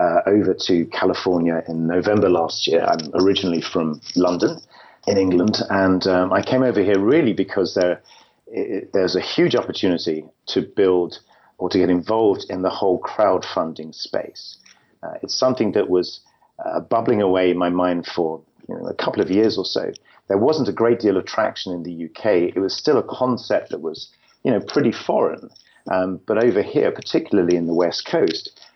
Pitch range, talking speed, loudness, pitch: 85-100 Hz, 185 wpm, -20 LUFS, 90 Hz